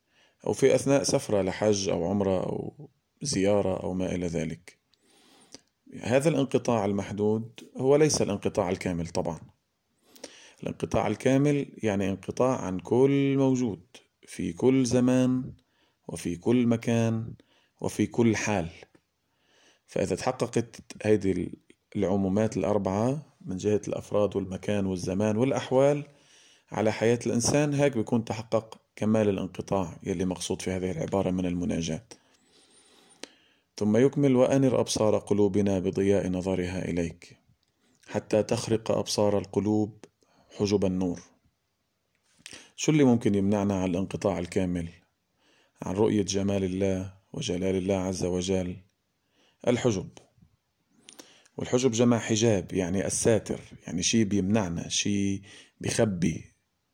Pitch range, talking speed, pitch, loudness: 95-120 Hz, 110 wpm, 105 Hz, -27 LUFS